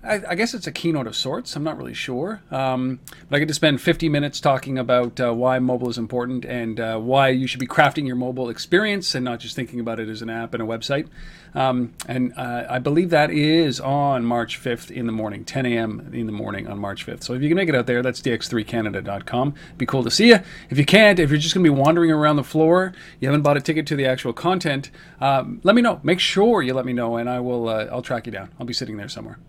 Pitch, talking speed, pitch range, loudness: 130 Hz, 265 wpm, 120-160 Hz, -21 LUFS